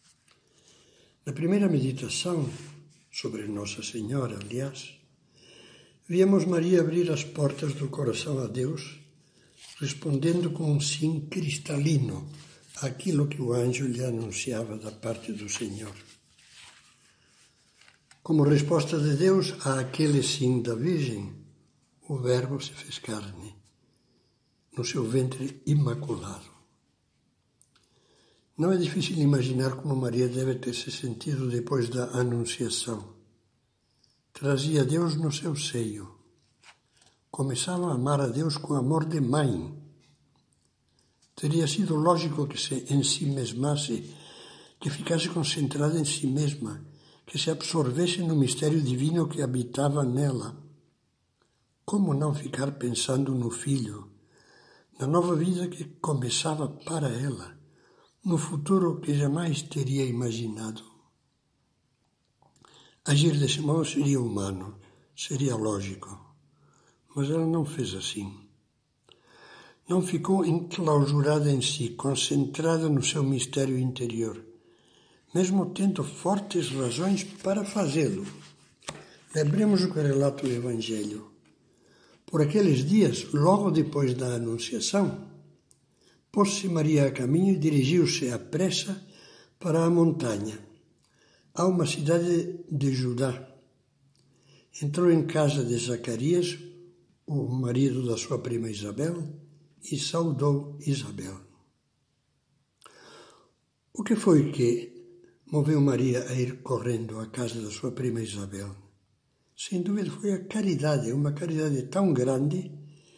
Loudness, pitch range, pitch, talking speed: -27 LUFS, 125-160 Hz, 140 Hz, 110 wpm